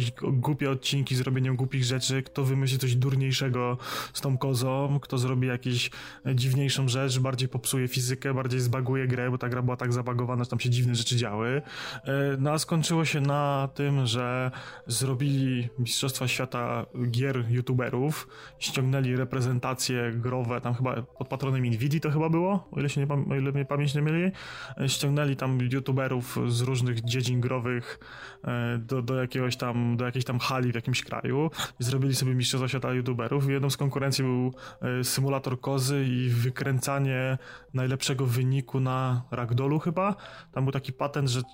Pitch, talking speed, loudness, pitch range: 130 Hz, 155 wpm, -28 LUFS, 125-135 Hz